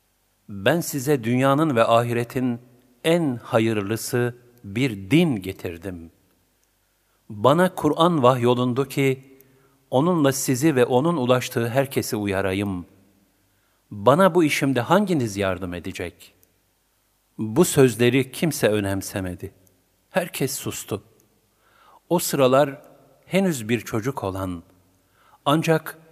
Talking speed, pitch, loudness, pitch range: 90 wpm, 120 Hz, -22 LUFS, 100-140 Hz